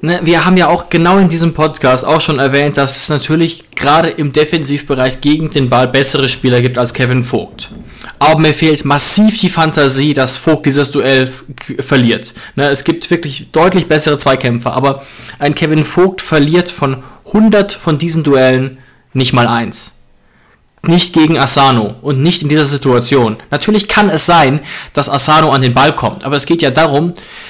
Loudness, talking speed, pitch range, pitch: -10 LUFS, 175 wpm, 135-165 Hz, 145 Hz